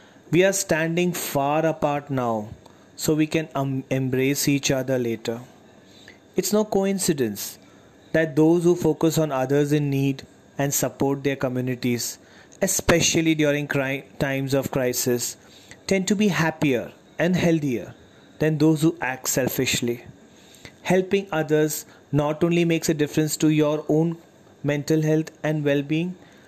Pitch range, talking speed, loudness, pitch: 130-160 Hz, 140 wpm, -23 LUFS, 150 Hz